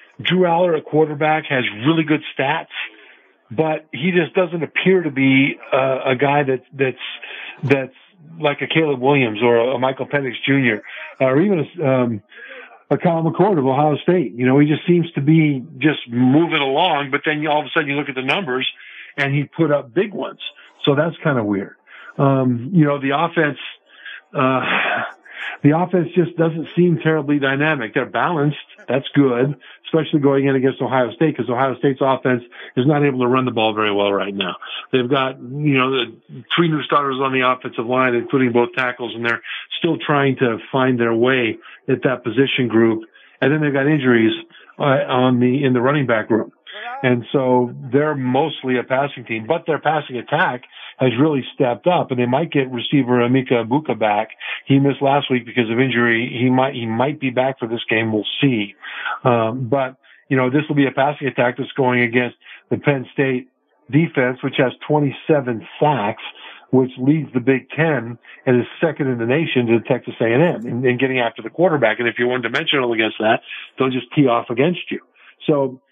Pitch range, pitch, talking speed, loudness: 125-150 Hz, 135 Hz, 195 wpm, -18 LUFS